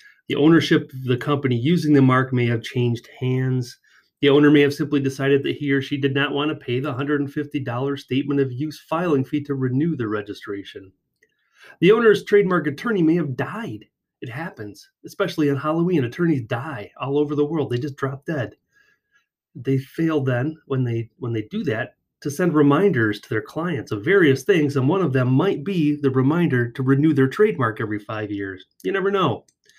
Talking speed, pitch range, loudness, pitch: 195 wpm, 130-155 Hz, -21 LUFS, 140 Hz